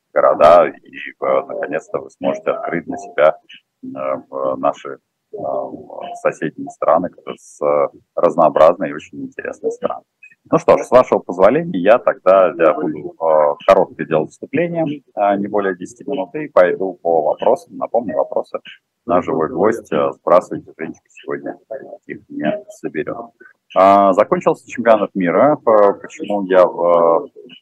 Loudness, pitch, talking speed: -16 LUFS, 105 Hz, 125 wpm